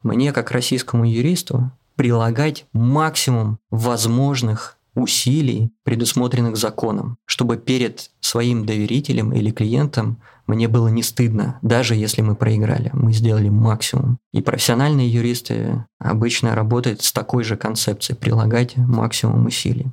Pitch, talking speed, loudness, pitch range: 120 Hz, 115 wpm, -19 LUFS, 115-130 Hz